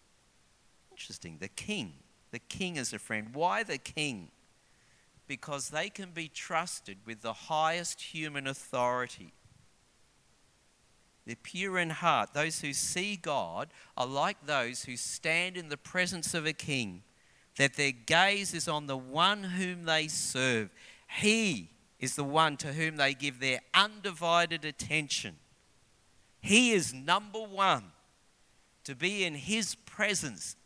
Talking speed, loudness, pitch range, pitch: 135 wpm, -31 LUFS, 130-180 Hz, 155 Hz